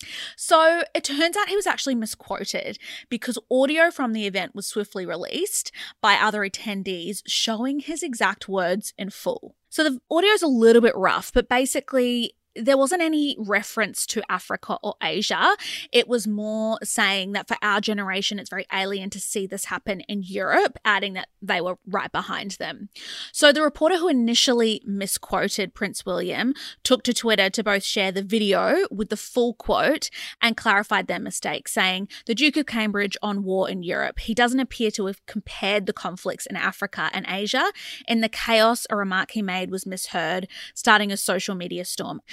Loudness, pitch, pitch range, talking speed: -23 LUFS, 215 Hz, 195-255 Hz, 180 wpm